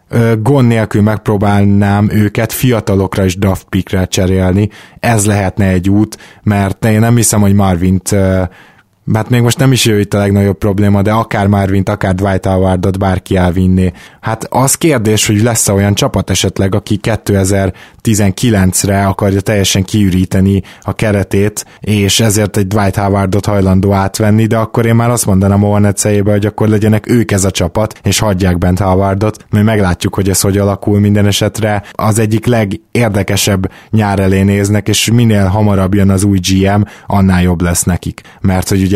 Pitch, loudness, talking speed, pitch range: 100 Hz, -11 LUFS, 165 wpm, 95-110 Hz